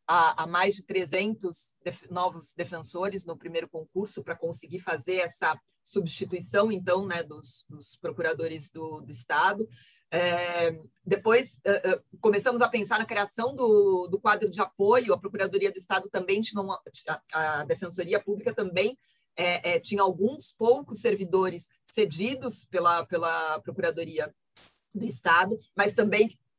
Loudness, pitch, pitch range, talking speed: -27 LUFS, 190 Hz, 170-210 Hz, 145 wpm